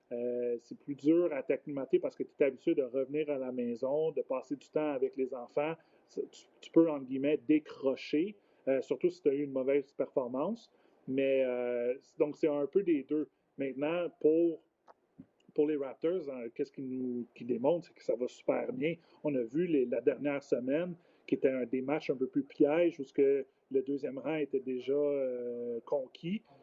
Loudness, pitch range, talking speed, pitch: -34 LUFS, 130-165 Hz, 195 wpm, 145 Hz